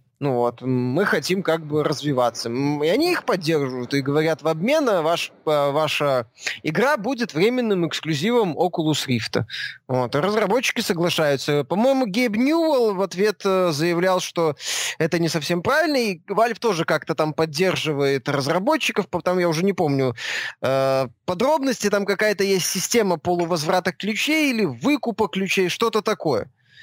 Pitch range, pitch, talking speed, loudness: 150-215 Hz, 175 Hz, 145 wpm, -21 LUFS